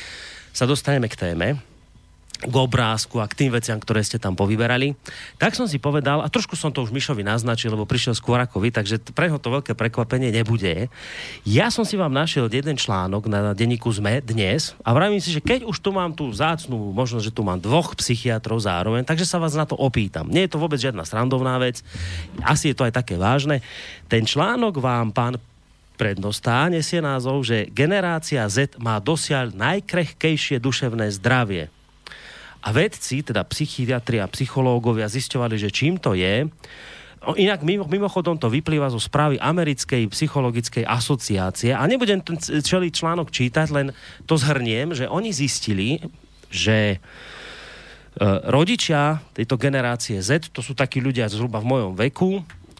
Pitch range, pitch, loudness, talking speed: 110-150 Hz, 130 Hz, -22 LUFS, 165 wpm